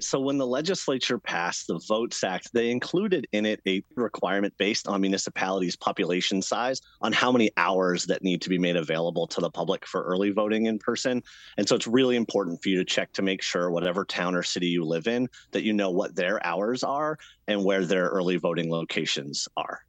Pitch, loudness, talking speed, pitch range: 100 Hz, -26 LUFS, 210 wpm, 90-115 Hz